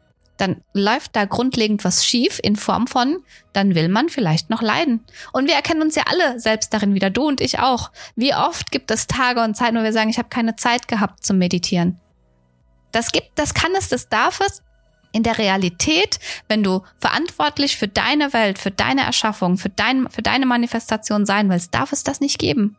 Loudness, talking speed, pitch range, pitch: -18 LUFS, 205 wpm, 200-260 Hz, 225 Hz